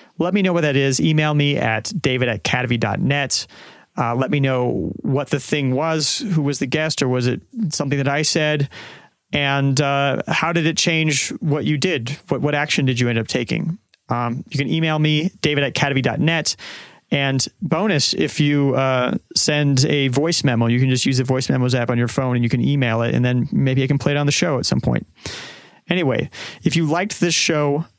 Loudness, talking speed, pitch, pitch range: -19 LUFS, 210 wpm, 140 Hz, 130-155 Hz